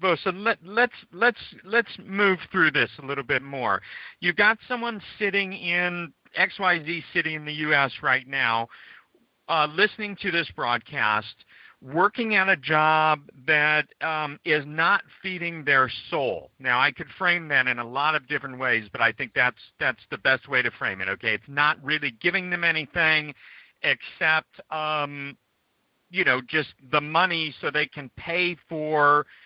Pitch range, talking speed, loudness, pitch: 145-190 Hz, 170 wpm, -24 LUFS, 155 Hz